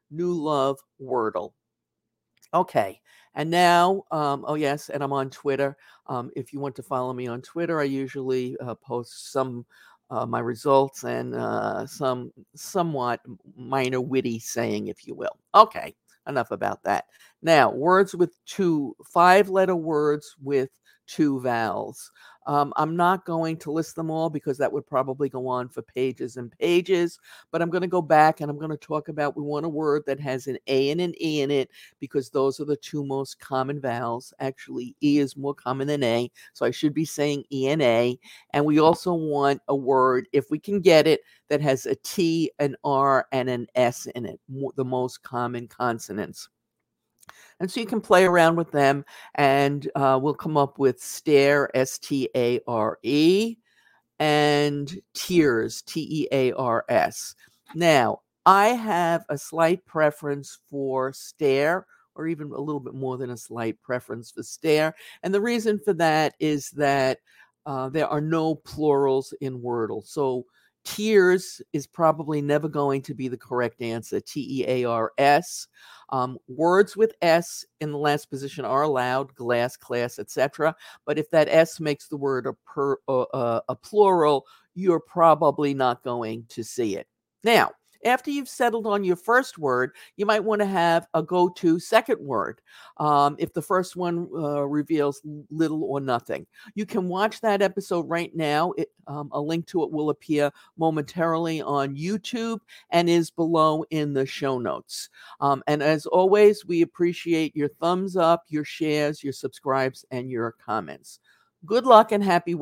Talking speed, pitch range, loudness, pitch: 175 wpm, 135-165 Hz, -24 LUFS, 145 Hz